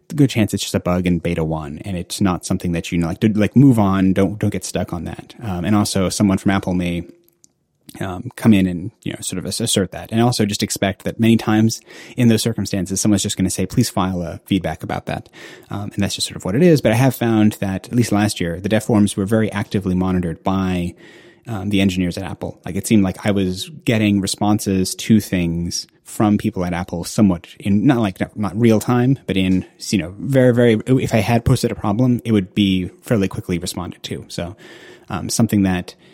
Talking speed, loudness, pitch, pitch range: 230 wpm, -18 LUFS, 100 Hz, 95-110 Hz